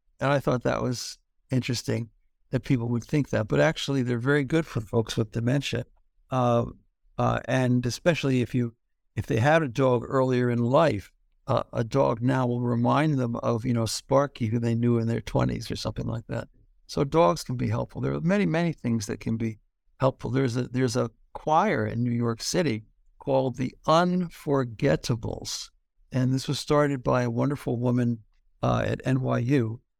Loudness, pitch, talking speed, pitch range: -26 LUFS, 125 Hz, 185 wpm, 115-135 Hz